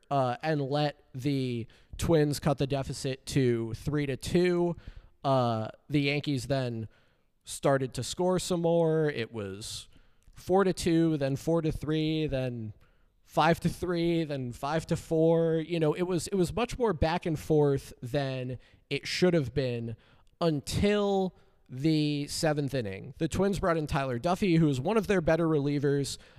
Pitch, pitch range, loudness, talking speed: 145 Hz, 130-165 Hz, -29 LUFS, 160 wpm